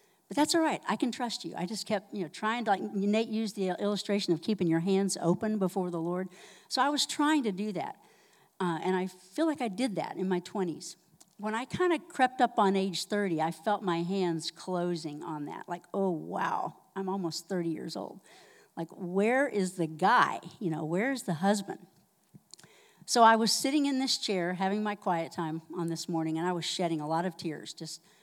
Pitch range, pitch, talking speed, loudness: 170-215 Hz, 190 Hz, 220 wpm, -31 LUFS